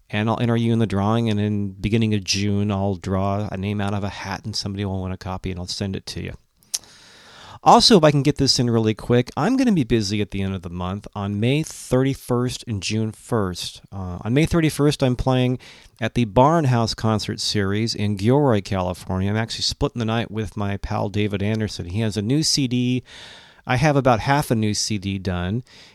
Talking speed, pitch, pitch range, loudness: 220 wpm, 110 Hz, 100-125 Hz, -21 LUFS